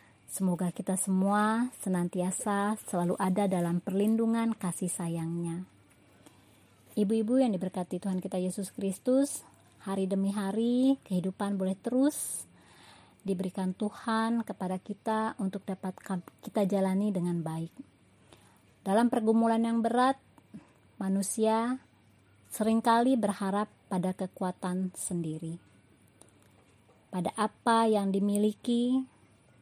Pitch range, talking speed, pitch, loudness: 180-225 Hz, 95 wpm, 195 Hz, -30 LUFS